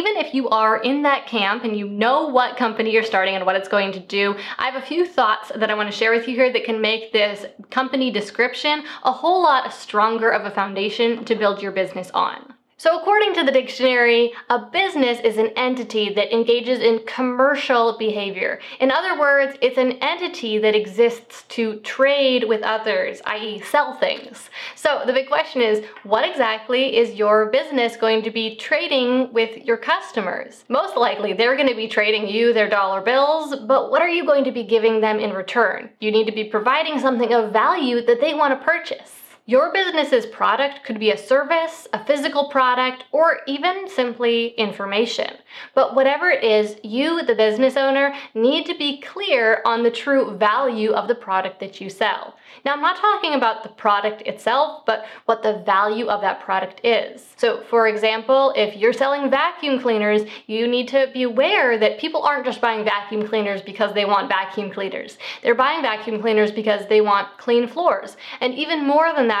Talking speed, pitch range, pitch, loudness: 195 wpm, 215-275 Hz, 235 Hz, -19 LUFS